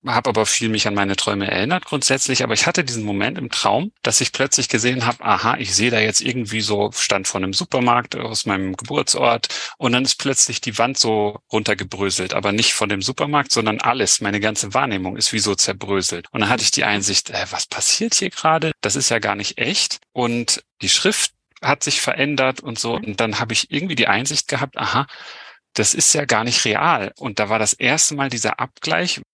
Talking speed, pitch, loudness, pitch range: 215 wpm, 110 Hz, -18 LUFS, 100-130 Hz